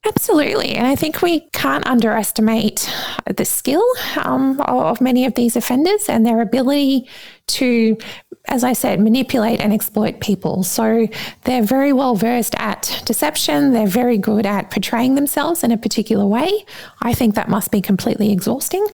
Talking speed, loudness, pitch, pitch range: 160 wpm, -17 LUFS, 240 Hz, 220-275 Hz